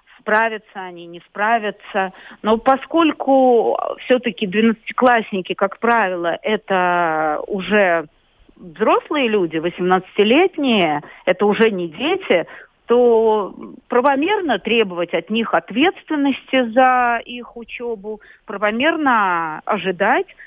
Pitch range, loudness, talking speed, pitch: 190-260 Hz, -17 LUFS, 90 wpm, 220 Hz